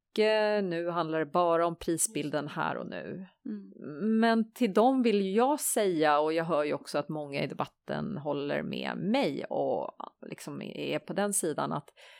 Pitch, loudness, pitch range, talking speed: 190 Hz, -30 LUFS, 160-220 Hz, 165 wpm